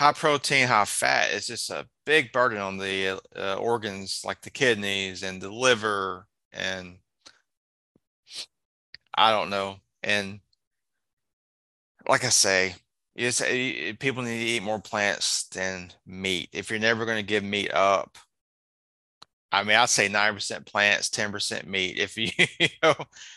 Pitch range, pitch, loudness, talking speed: 95-115 Hz, 100 Hz, -25 LUFS, 150 wpm